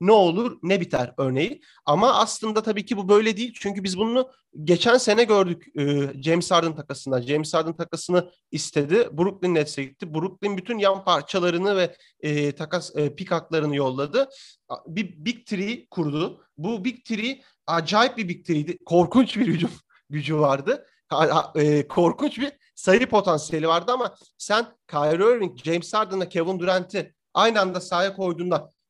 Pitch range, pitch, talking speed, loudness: 160-215 Hz, 180 Hz, 150 wpm, -23 LUFS